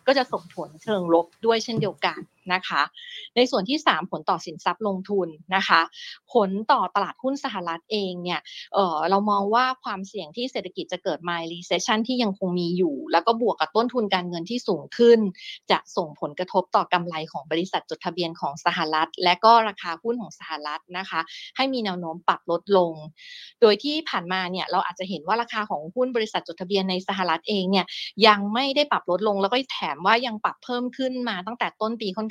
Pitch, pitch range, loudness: 195 Hz, 175-230 Hz, -24 LUFS